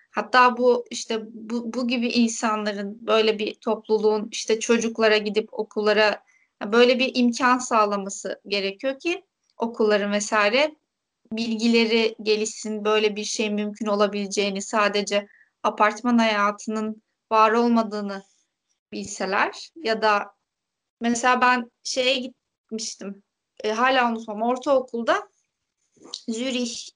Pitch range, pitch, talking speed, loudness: 210-240 Hz, 220 Hz, 100 wpm, -23 LUFS